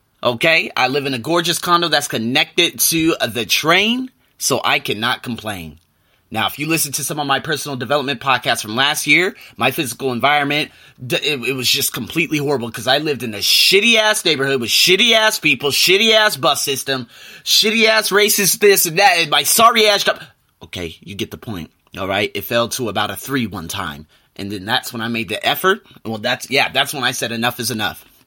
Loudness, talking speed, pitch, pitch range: -15 LUFS, 200 wpm, 140 Hz, 115-170 Hz